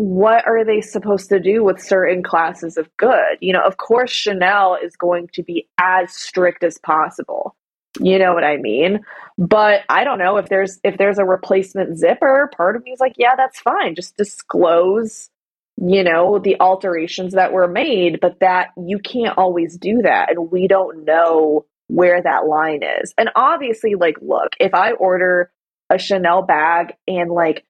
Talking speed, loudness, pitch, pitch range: 180 wpm, -16 LUFS, 185 Hz, 175-205 Hz